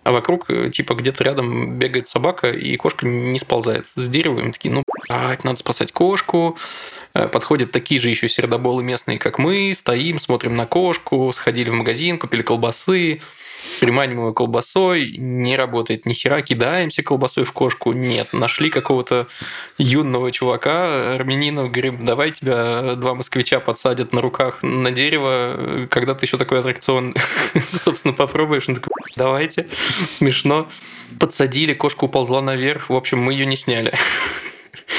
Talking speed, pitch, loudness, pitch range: 140 wpm, 130 Hz, -18 LUFS, 125-140 Hz